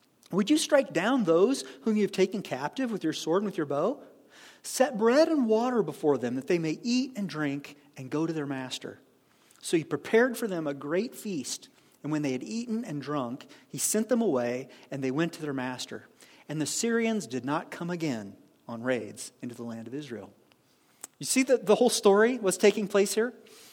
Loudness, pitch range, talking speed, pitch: -28 LUFS, 145-225 Hz, 210 wpm, 180 Hz